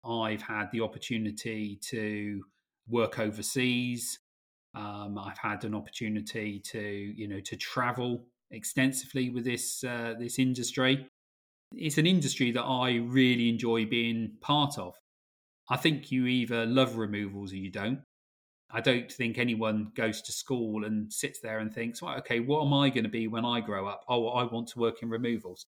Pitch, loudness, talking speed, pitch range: 115 Hz, -31 LUFS, 170 wpm, 105-125 Hz